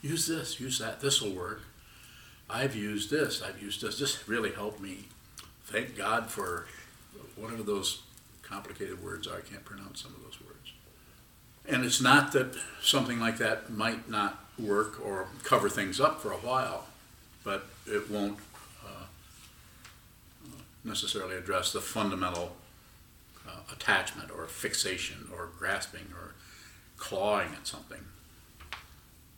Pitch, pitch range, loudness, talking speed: 105 Hz, 95-120 Hz, -31 LUFS, 140 wpm